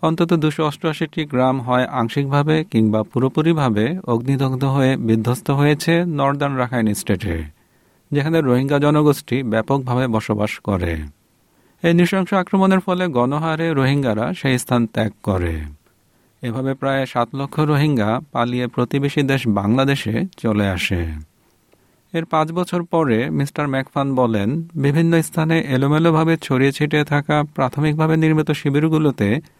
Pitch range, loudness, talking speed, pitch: 120-155 Hz, -19 LUFS, 115 wpm, 140 Hz